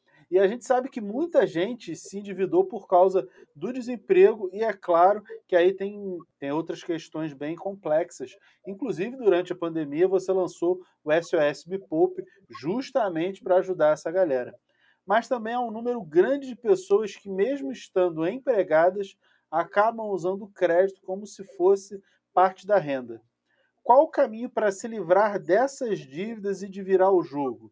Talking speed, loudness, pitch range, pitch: 160 wpm, -25 LUFS, 175-225 Hz, 190 Hz